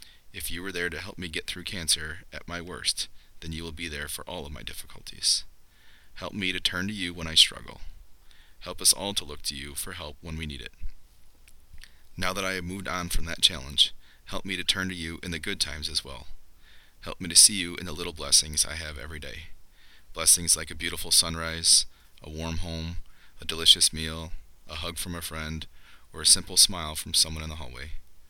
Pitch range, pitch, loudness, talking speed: 75-90 Hz, 80 Hz, -24 LUFS, 220 wpm